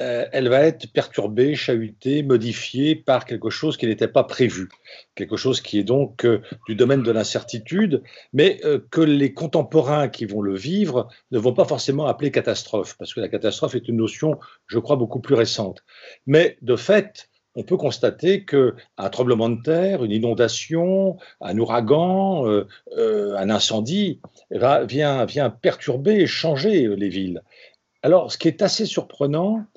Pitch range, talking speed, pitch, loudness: 115-175 Hz, 155 wpm, 140 Hz, -21 LUFS